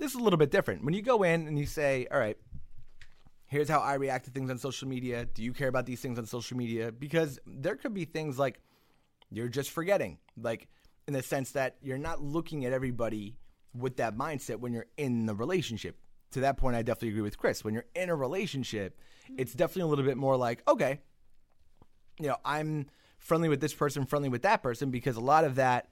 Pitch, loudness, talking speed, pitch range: 135 Hz, -32 LUFS, 225 wpm, 120-150 Hz